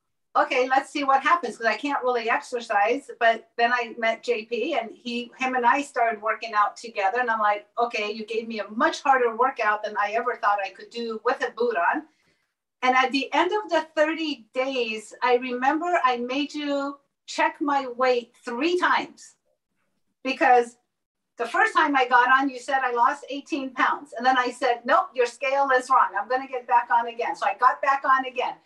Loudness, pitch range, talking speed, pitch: -24 LUFS, 235-275 Hz, 205 wpm, 250 Hz